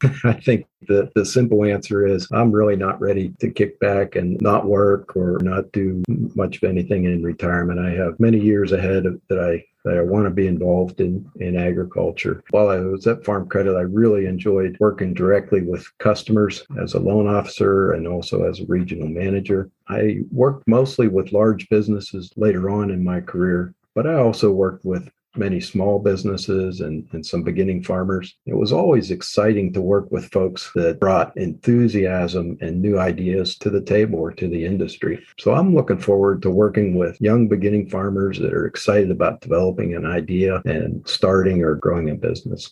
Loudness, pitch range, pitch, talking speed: -20 LUFS, 90-105 Hz, 95 Hz, 185 wpm